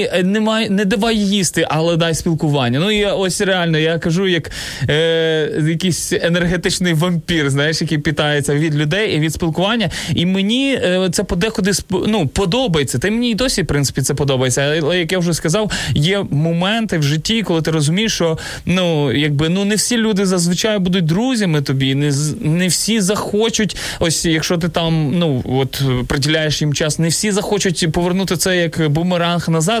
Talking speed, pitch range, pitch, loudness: 175 wpm, 155-195 Hz, 170 Hz, -16 LUFS